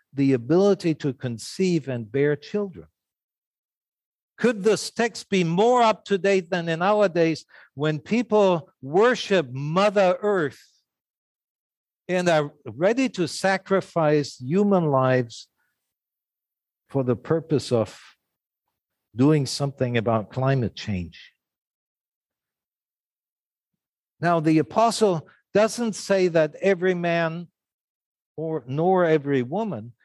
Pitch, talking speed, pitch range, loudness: 170 Hz, 105 wpm, 140-195 Hz, -23 LUFS